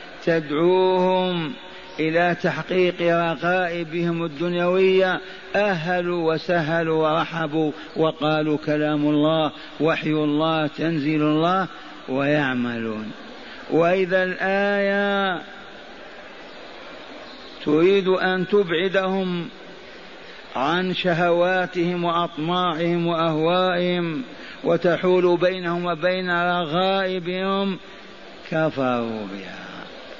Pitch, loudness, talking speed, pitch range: 170 Hz, -22 LUFS, 60 wpm, 155-185 Hz